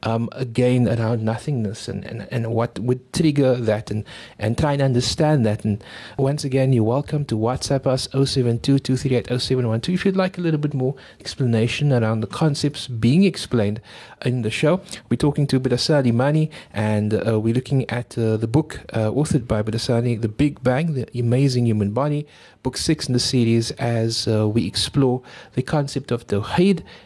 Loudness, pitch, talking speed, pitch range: -21 LUFS, 125 Hz, 175 wpm, 115-140 Hz